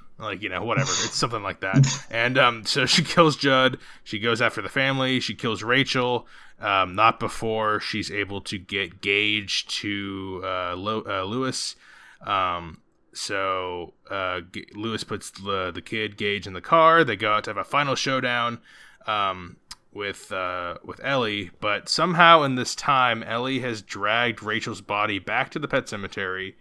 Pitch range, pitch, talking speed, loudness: 100-130 Hz, 110 Hz, 170 wpm, -23 LUFS